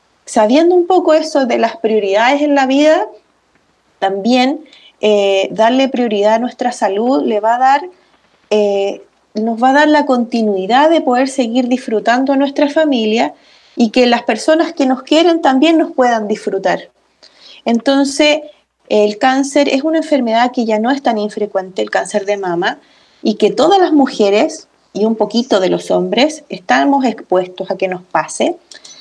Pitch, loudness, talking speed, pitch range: 250 Hz, -13 LUFS, 165 wpm, 215-290 Hz